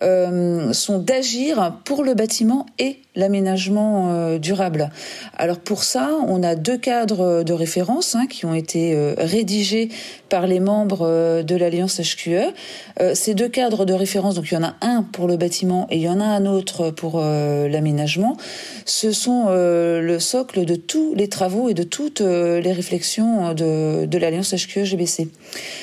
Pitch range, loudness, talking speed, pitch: 170-225 Hz, -20 LUFS, 175 wpm, 185 Hz